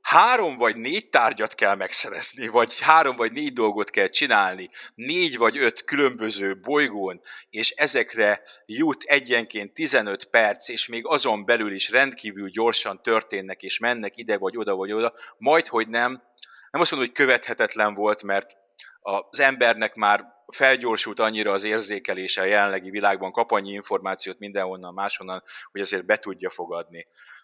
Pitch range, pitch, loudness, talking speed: 100-120 Hz, 105 Hz, -22 LUFS, 150 wpm